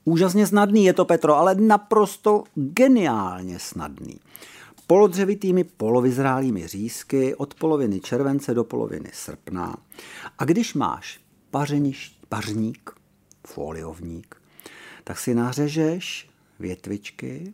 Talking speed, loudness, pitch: 95 wpm, -22 LUFS, 140 Hz